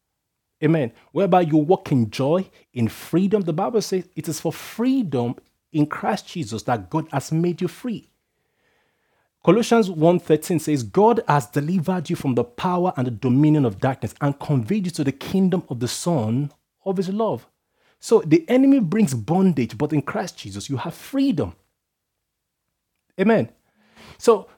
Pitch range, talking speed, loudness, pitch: 140-190 Hz, 160 wpm, -21 LUFS, 165 Hz